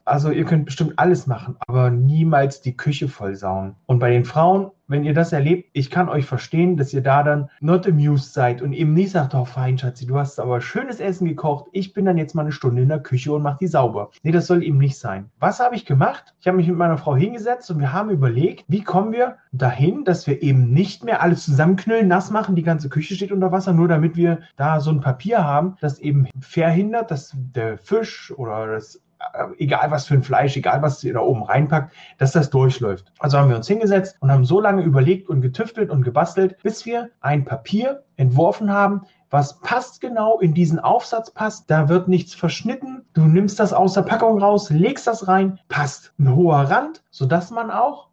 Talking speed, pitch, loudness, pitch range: 220 wpm, 165 Hz, -19 LUFS, 140-190 Hz